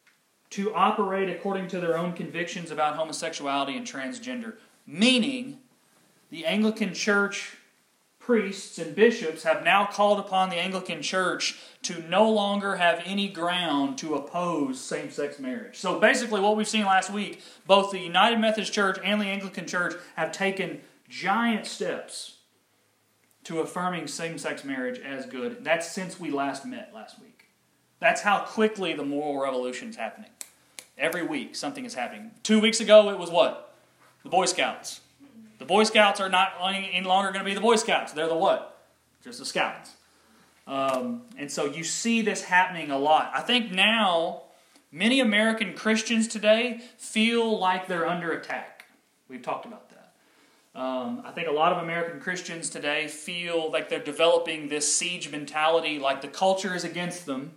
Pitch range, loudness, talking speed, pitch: 165-220 Hz, -26 LUFS, 165 wpm, 190 Hz